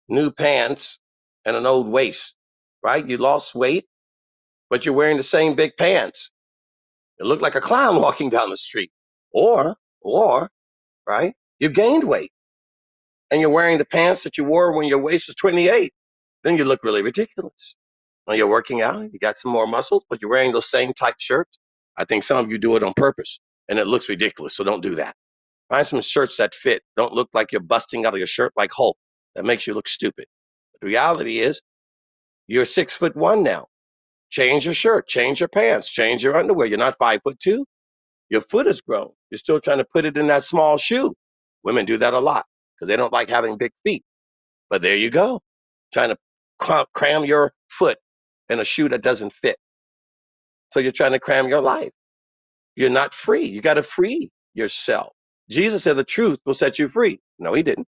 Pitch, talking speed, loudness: 155 Hz, 200 wpm, -19 LUFS